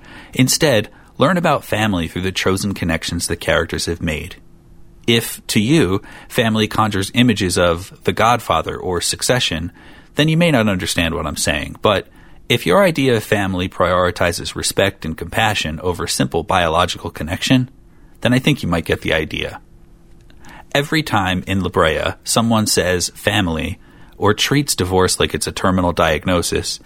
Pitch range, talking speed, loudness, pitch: 85-110 Hz, 150 wpm, -17 LUFS, 95 Hz